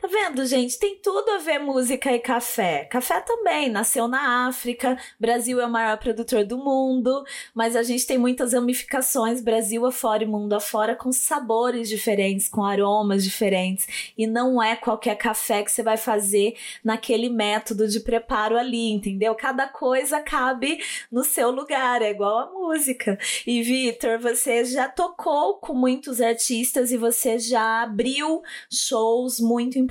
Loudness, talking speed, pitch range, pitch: -23 LUFS, 160 wpm, 225-260 Hz, 240 Hz